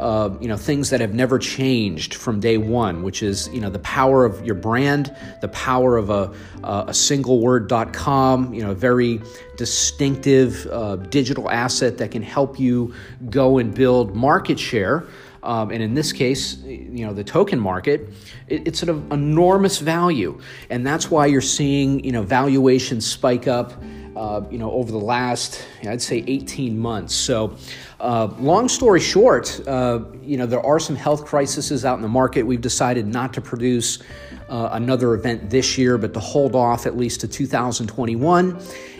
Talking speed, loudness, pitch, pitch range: 185 wpm, -19 LUFS, 125 Hz, 110-135 Hz